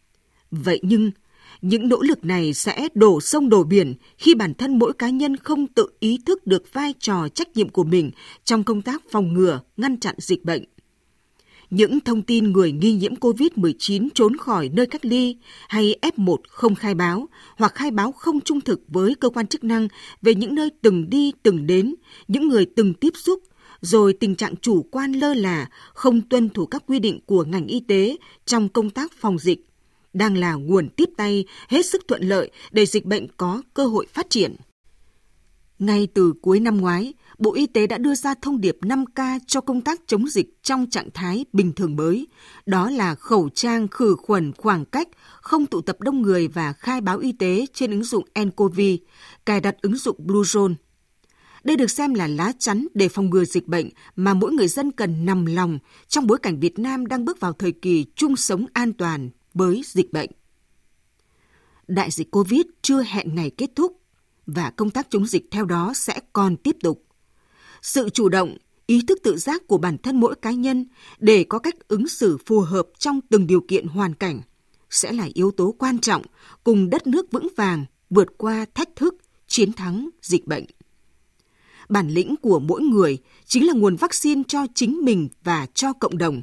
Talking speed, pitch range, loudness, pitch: 195 wpm, 185-260 Hz, -21 LUFS, 210 Hz